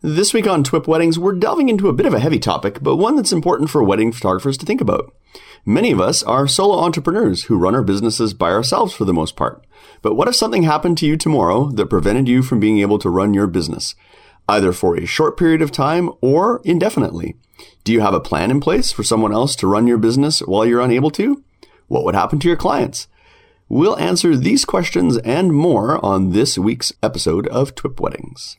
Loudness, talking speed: -16 LUFS, 220 wpm